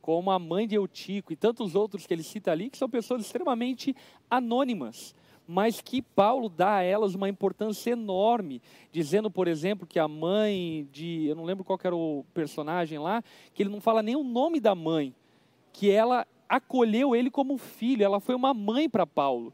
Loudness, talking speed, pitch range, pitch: -28 LUFS, 190 wpm, 180-240 Hz, 205 Hz